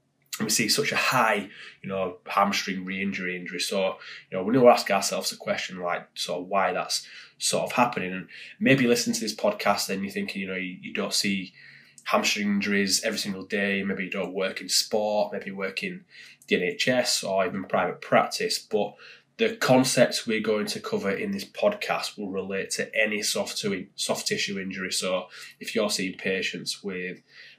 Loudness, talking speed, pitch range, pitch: -26 LUFS, 200 wpm, 95-110 Hz, 100 Hz